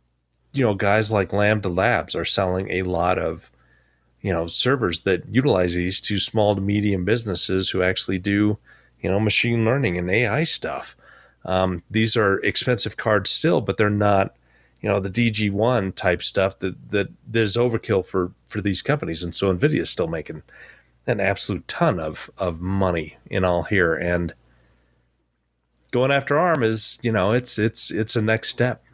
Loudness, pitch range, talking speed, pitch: -21 LUFS, 90-110 Hz, 170 wpm, 95 Hz